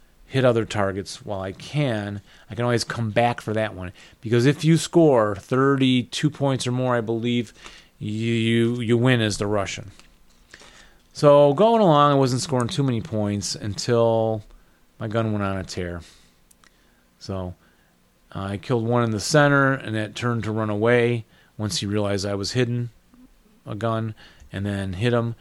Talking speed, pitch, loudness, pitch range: 170 wpm, 115 Hz, -22 LUFS, 100-125 Hz